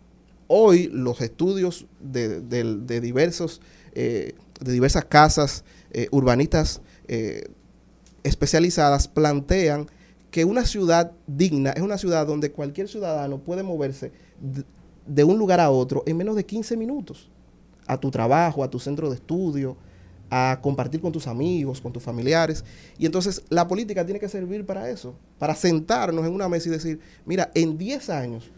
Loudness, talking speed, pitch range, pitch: -23 LUFS, 155 wpm, 135-175 Hz, 155 Hz